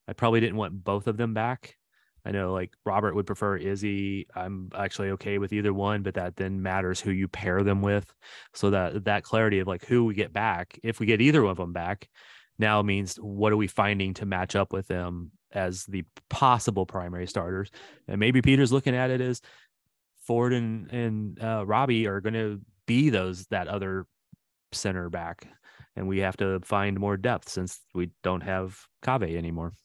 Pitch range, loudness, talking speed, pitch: 95-110 Hz, -28 LUFS, 195 wpm, 100 Hz